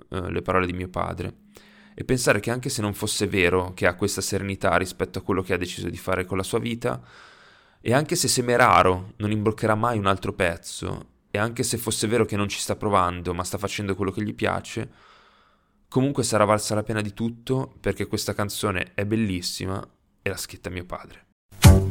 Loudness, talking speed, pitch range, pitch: -24 LUFS, 200 wpm, 95-110 Hz, 100 Hz